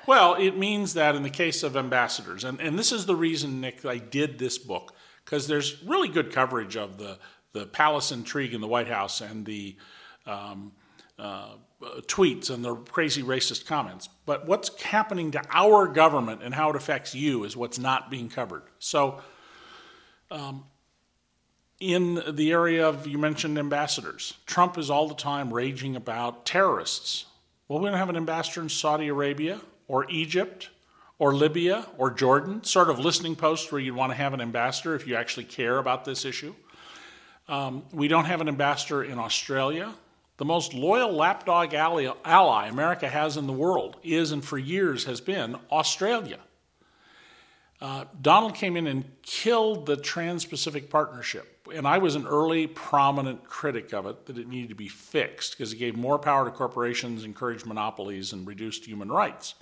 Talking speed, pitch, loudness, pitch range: 175 wpm, 145 Hz, -26 LUFS, 125-165 Hz